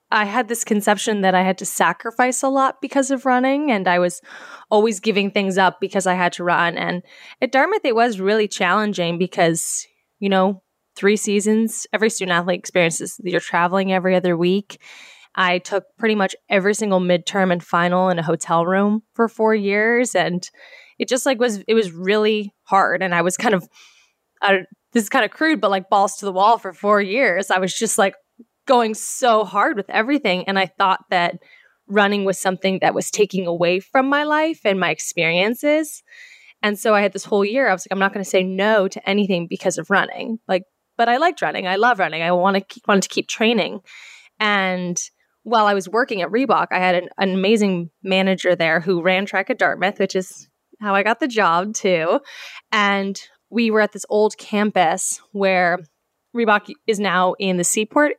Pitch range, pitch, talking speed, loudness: 185-225 Hz, 200 Hz, 200 wpm, -19 LUFS